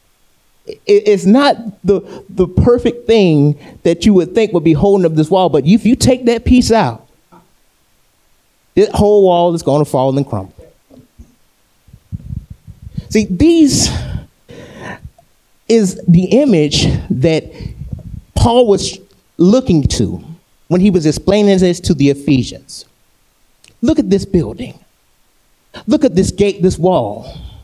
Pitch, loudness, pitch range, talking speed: 185 Hz, -12 LUFS, 155-220 Hz, 130 wpm